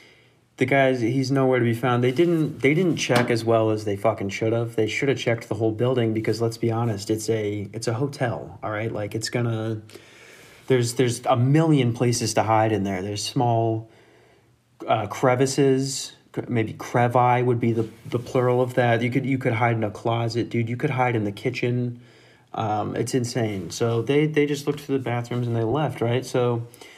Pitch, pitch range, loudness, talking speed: 120 Hz, 110-130 Hz, -23 LUFS, 205 wpm